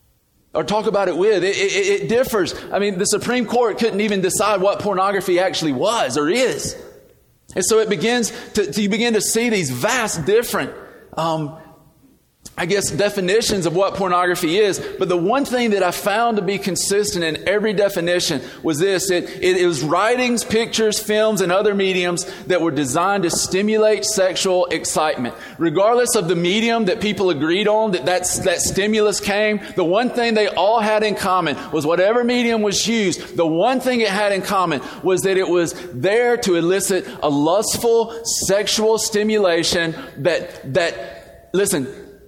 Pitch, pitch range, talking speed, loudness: 200 Hz, 180-220 Hz, 175 wpm, -18 LUFS